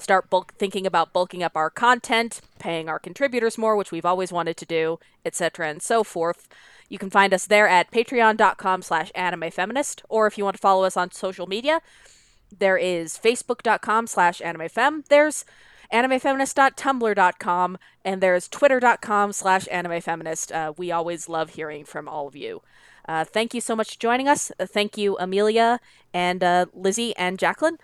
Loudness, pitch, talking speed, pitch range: -22 LUFS, 190 Hz, 160 wpm, 175-230 Hz